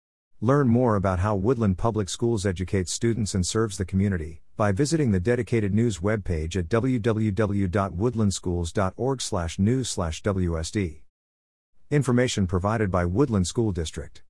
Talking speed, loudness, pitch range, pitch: 115 wpm, -25 LUFS, 90-115 Hz, 100 Hz